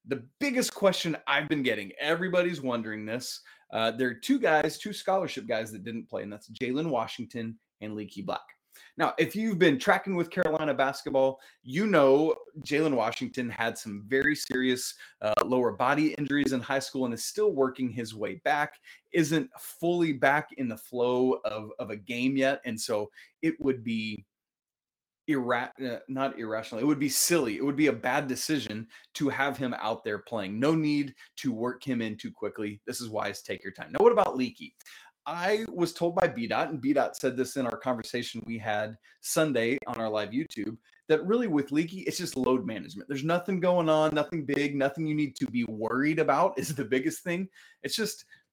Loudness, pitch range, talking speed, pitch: -29 LUFS, 120-165 Hz, 195 wpm, 135 Hz